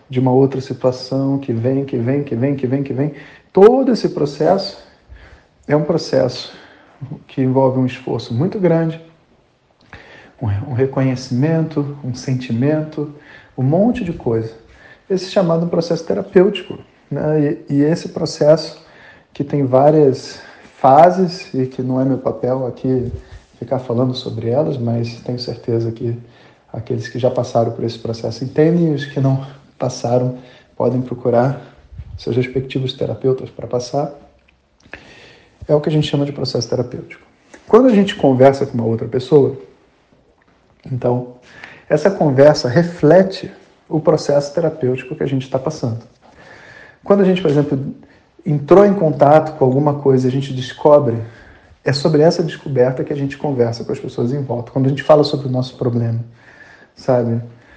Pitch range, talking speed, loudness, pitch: 125-155 Hz, 150 wpm, -16 LUFS, 135 Hz